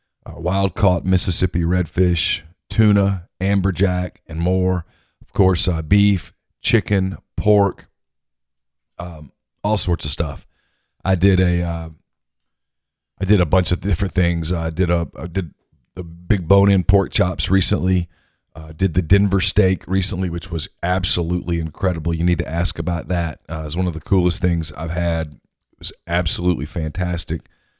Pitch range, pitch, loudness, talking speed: 85-95 Hz, 90 Hz, -19 LUFS, 160 wpm